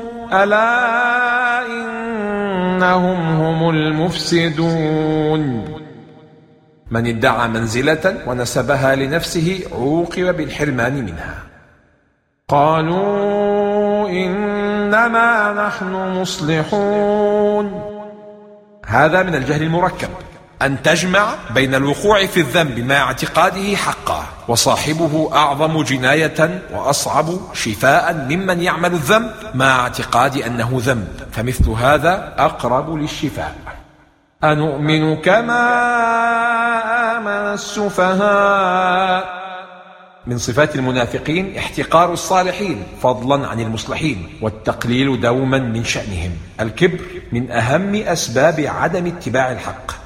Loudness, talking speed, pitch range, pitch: -16 LUFS, 80 wpm, 135-205 Hz, 165 Hz